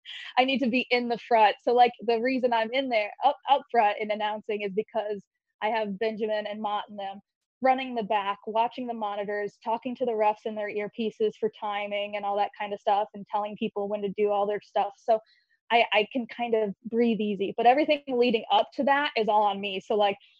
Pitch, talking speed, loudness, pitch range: 220 Hz, 230 wpm, -27 LUFS, 205-240 Hz